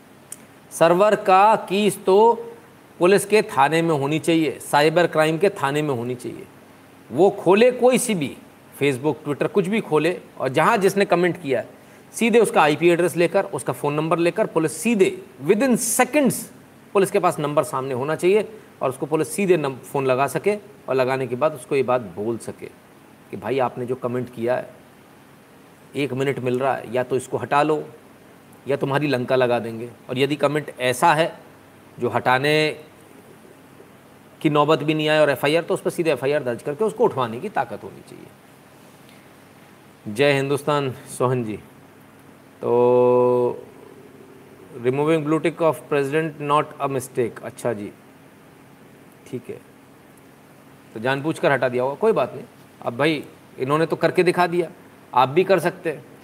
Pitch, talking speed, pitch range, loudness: 155 Hz, 170 wpm, 130-180 Hz, -21 LUFS